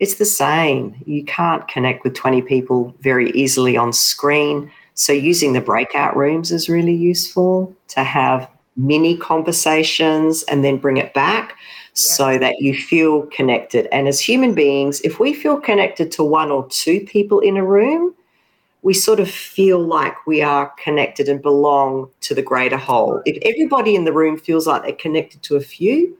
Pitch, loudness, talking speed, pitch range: 155 Hz, -16 LUFS, 175 wpm, 140-185 Hz